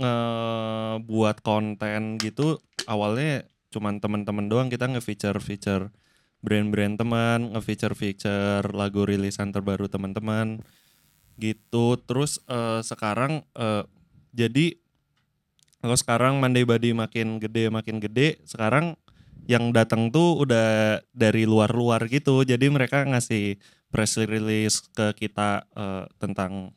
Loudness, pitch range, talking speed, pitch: -25 LUFS, 105-120 Hz, 115 wpm, 110 Hz